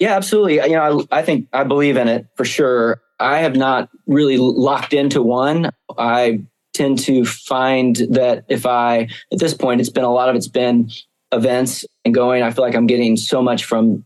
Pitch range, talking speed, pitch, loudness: 120-135 Hz, 205 wpm, 125 Hz, -16 LUFS